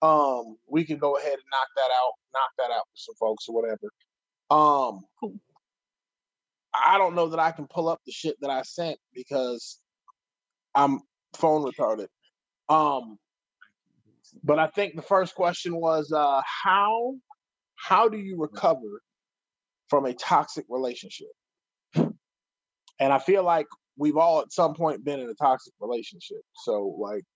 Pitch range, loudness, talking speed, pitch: 140-195 Hz, -25 LUFS, 150 wpm, 160 Hz